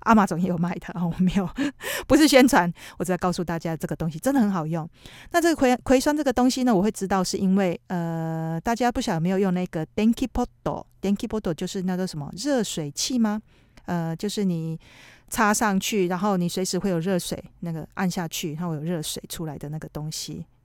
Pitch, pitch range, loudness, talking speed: 185 Hz, 165-220 Hz, -24 LUFS, 355 characters per minute